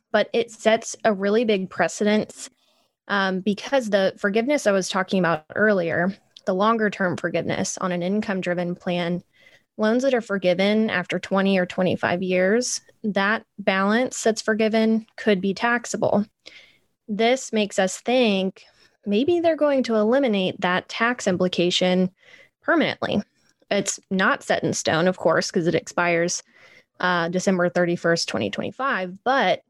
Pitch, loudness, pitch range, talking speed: 200 Hz, -22 LUFS, 180-225 Hz, 140 wpm